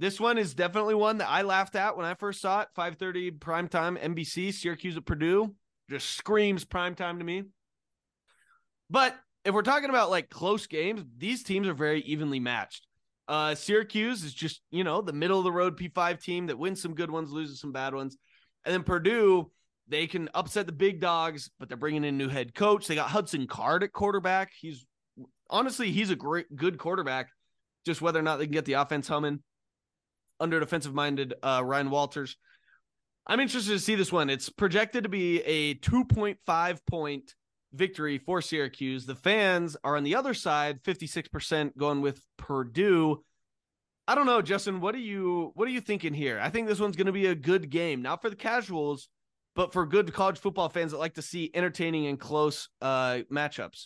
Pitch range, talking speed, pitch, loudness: 150-195 Hz, 195 wpm, 170 Hz, -29 LUFS